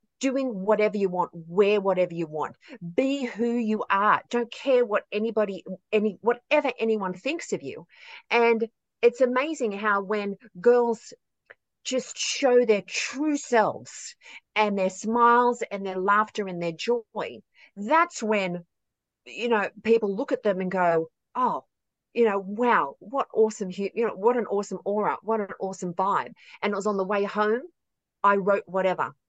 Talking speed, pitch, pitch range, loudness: 160 wpm, 215 Hz, 200-240 Hz, -25 LUFS